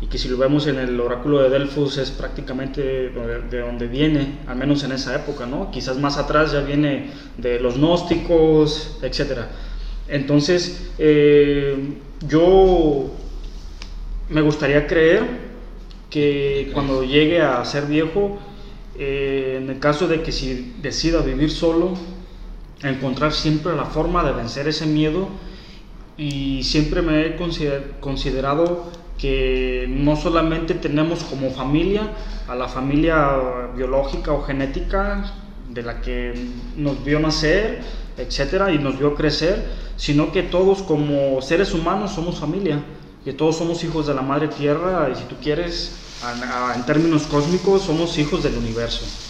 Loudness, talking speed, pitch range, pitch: -20 LUFS, 140 wpm, 135-165 Hz, 145 Hz